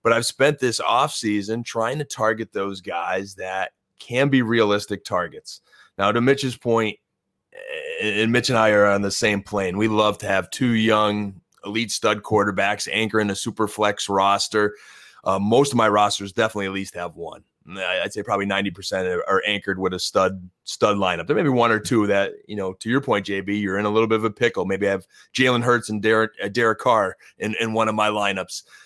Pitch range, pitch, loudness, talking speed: 100-115 Hz, 105 Hz, -21 LUFS, 210 wpm